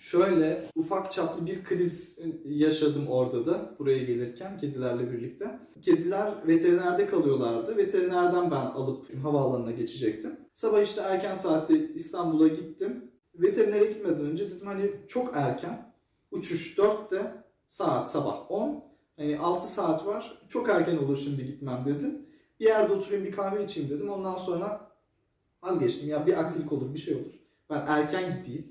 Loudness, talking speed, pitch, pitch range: -29 LUFS, 145 wpm, 175 Hz, 150-210 Hz